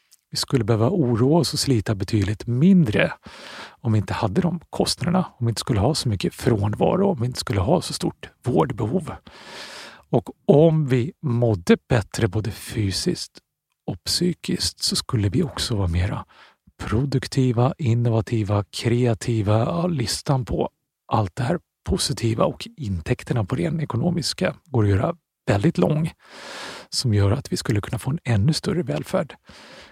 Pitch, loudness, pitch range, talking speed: 120 Hz, -22 LUFS, 110-150 Hz, 155 wpm